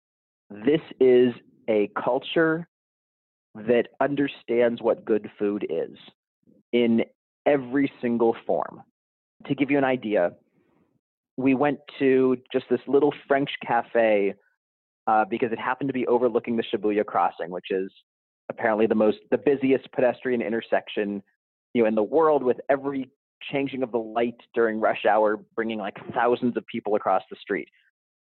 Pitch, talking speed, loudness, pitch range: 120 Hz, 145 wpm, -24 LUFS, 110-135 Hz